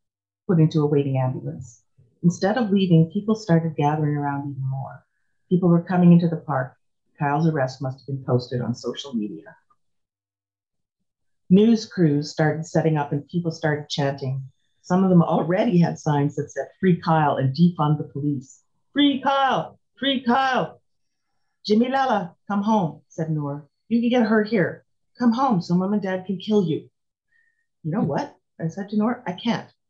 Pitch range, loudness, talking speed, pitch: 140-200 Hz, -22 LUFS, 170 wpm, 160 Hz